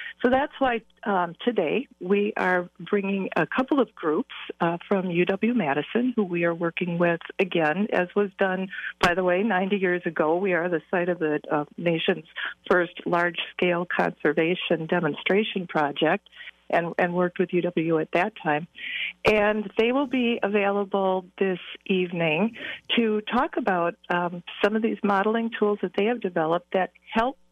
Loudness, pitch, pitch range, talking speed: -25 LUFS, 185 Hz, 175-210 Hz, 165 wpm